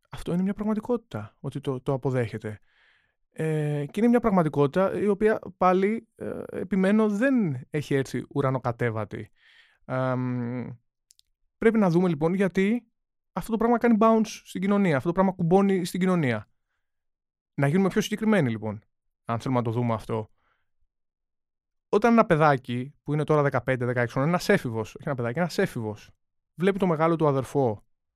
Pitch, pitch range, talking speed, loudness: 145 Hz, 120-195 Hz, 150 wpm, -25 LUFS